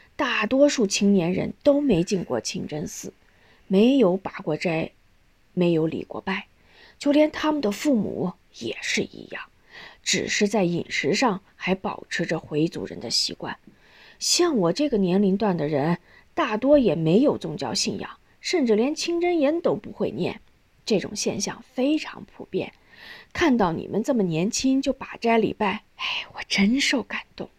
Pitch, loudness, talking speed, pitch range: 210 Hz, -24 LUFS, 230 characters per minute, 180-270 Hz